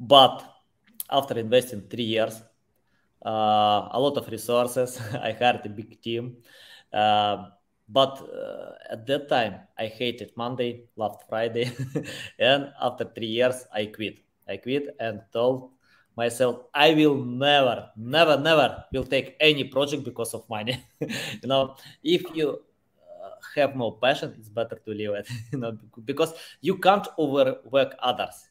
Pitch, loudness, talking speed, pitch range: 120 Hz, -25 LUFS, 145 wpm, 110-135 Hz